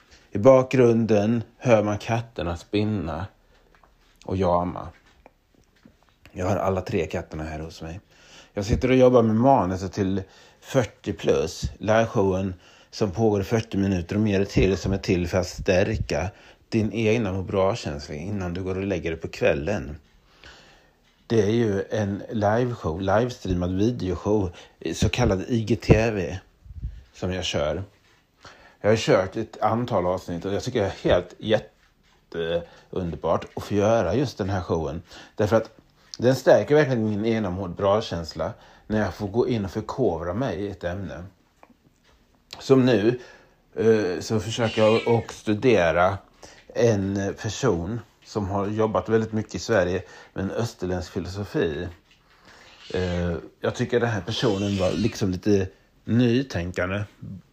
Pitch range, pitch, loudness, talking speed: 90-115 Hz, 100 Hz, -24 LUFS, 140 wpm